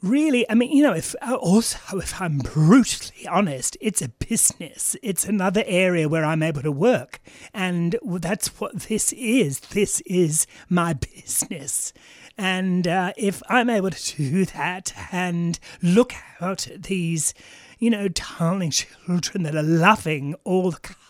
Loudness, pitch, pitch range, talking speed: -22 LUFS, 185 Hz, 165-215 Hz, 150 wpm